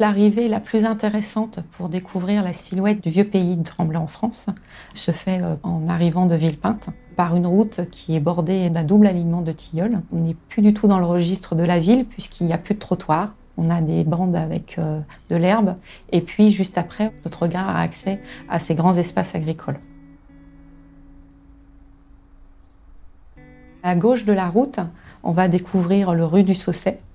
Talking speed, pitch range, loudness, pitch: 180 wpm, 165-195 Hz, -20 LUFS, 175 Hz